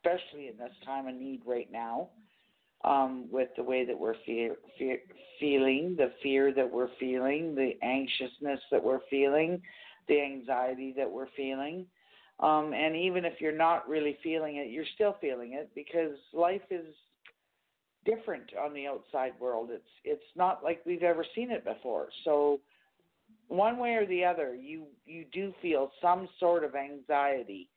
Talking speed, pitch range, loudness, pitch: 165 wpm, 135-175 Hz, -32 LUFS, 145 Hz